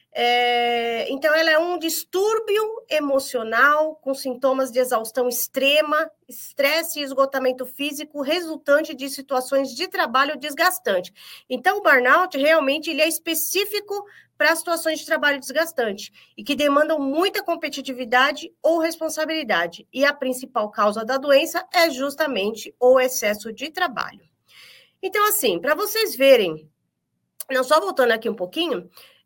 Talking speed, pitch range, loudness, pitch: 130 wpm, 255-325 Hz, -21 LUFS, 290 Hz